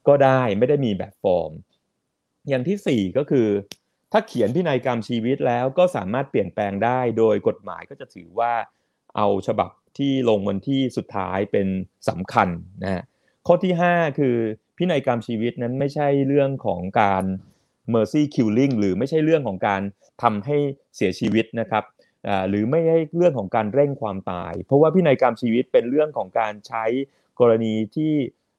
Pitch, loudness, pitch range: 120 Hz, -22 LUFS, 105-140 Hz